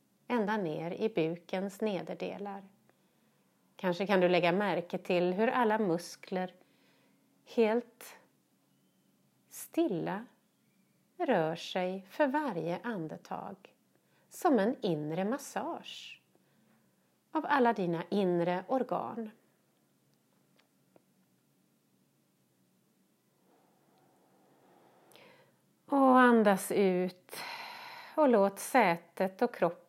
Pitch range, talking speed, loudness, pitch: 180-250 Hz, 75 wpm, -31 LUFS, 200 Hz